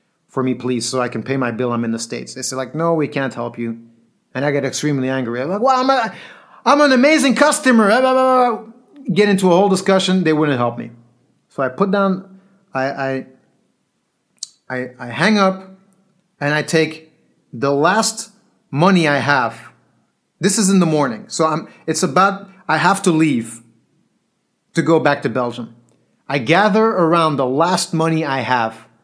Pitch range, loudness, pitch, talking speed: 130-195 Hz, -17 LUFS, 160 Hz, 180 wpm